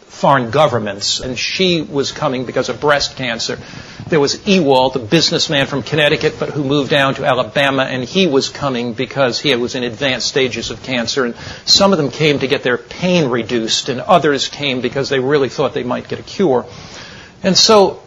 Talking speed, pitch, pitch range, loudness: 195 wpm, 135 Hz, 125-150 Hz, -15 LUFS